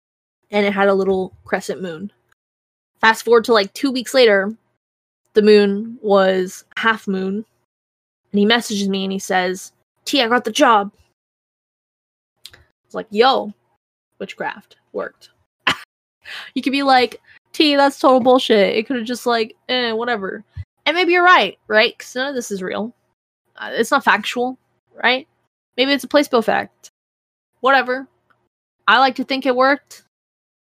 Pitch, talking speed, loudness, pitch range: 235 Hz, 155 wpm, -17 LUFS, 205-265 Hz